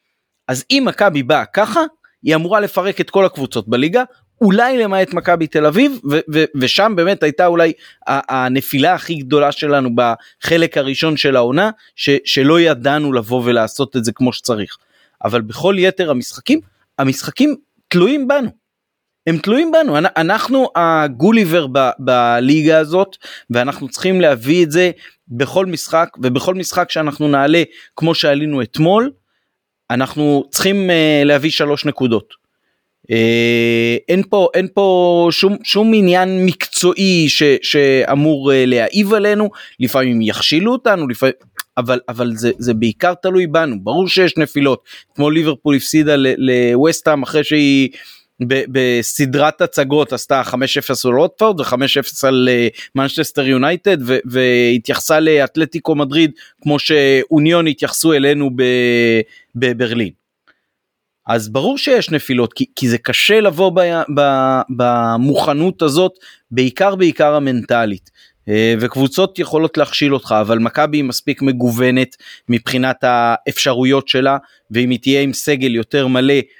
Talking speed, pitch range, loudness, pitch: 130 wpm, 130-175 Hz, -14 LUFS, 145 Hz